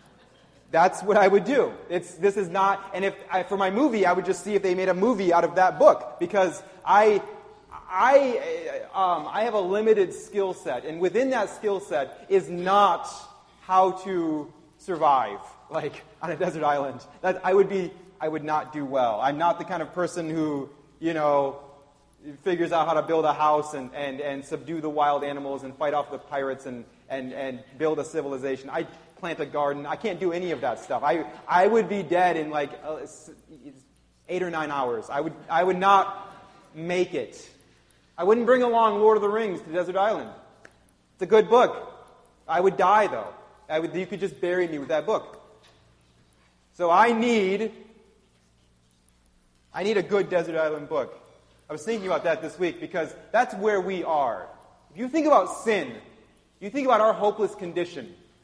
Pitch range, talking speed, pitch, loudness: 150-205 Hz, 195 wpm, 180 Hz, -24 LUFS